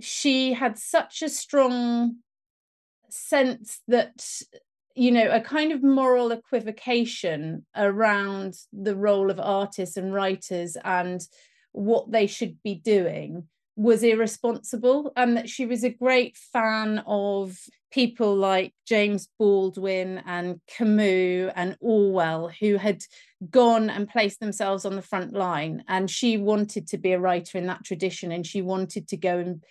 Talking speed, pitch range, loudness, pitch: 145 wpm, 190-235 Hz, -24 LUFS, 210 Hz